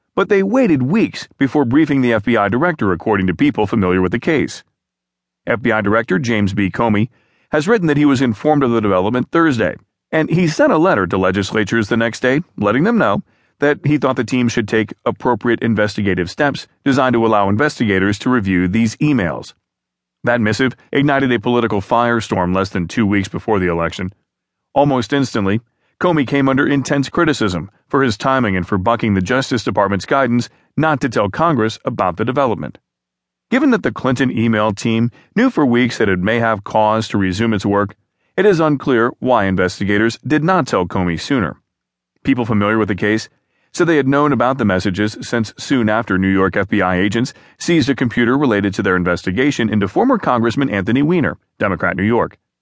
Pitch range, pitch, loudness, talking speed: 100-135 Hz, 115 Hz, -16 LUFS, 185 wpm